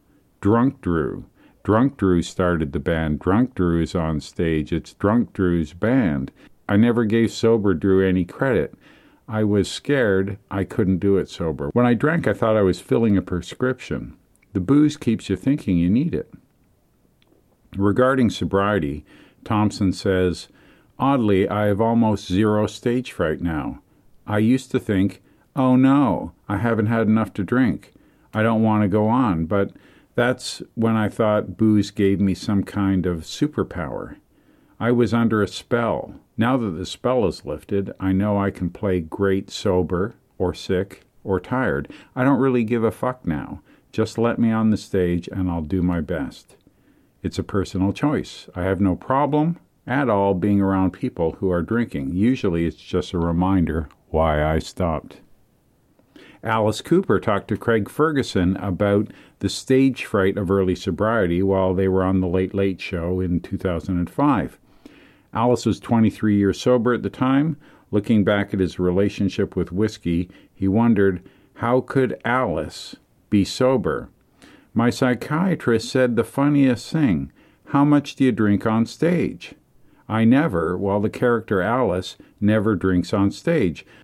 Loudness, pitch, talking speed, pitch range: -21 LUFS, 100 Hz, 160 wpm, 95-115 Hz